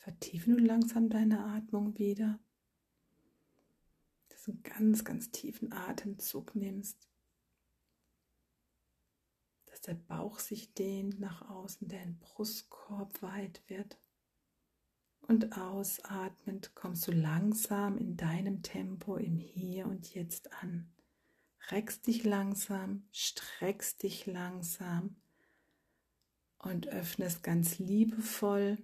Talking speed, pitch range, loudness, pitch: 100 wpm, 180-210 Hz, -36 LUFS, 195 Hz